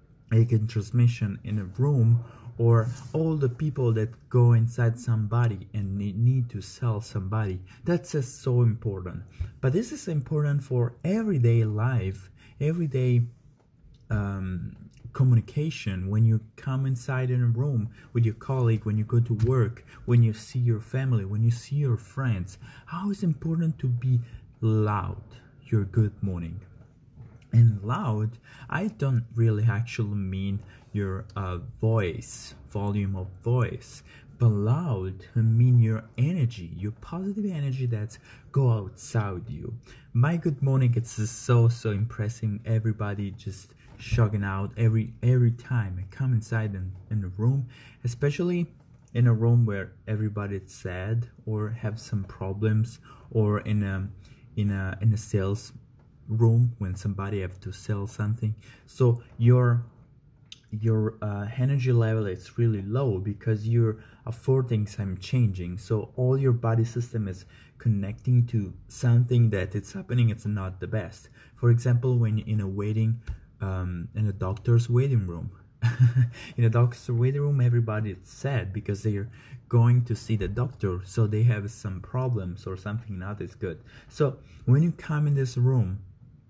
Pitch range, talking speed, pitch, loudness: 105-125 Hz, 145 wpm, 115 Hz, -27 LUFS